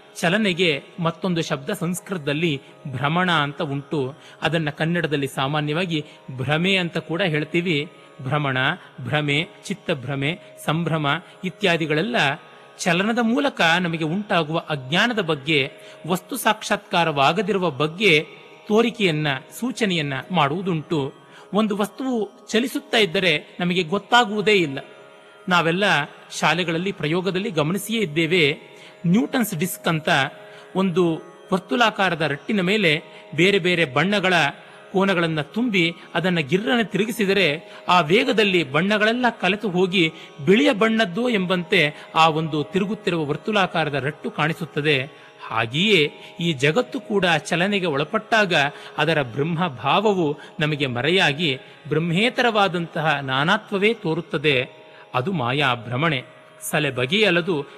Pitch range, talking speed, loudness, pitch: 150-200 Hz, 95 wpm, -21 LUFS, 170 Hz